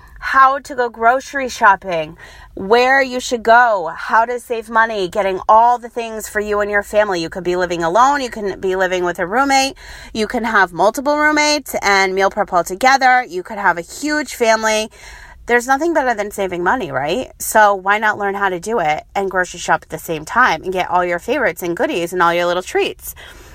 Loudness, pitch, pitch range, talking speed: -16 LUFS, 210 Hz, 185-250 Hz, 215 wpm